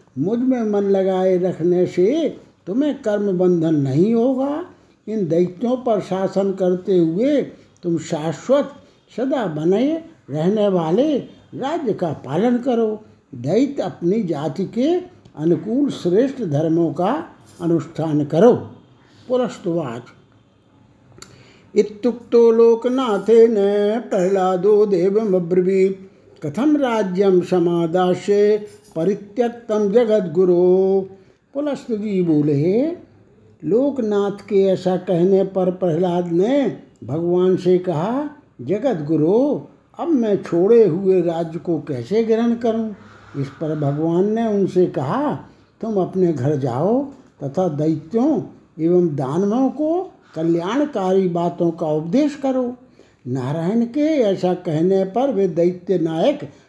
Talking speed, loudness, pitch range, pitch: 105 wpm, -19 LUFS, 170-230 Hz, 190 Hz